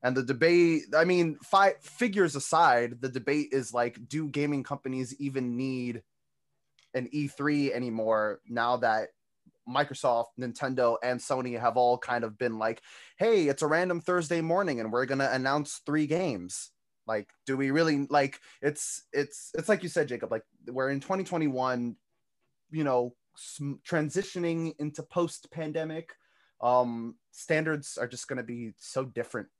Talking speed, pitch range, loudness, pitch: 155 wpm, 125-155 Hz, -29 LUFS, 135 Hz